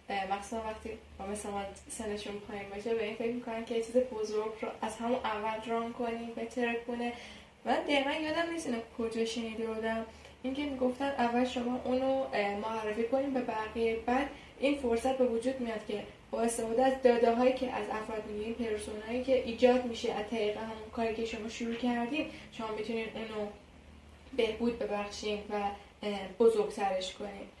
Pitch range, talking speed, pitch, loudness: 215-245 Hz, 170 wpm, 230 Hz, -34 LUFS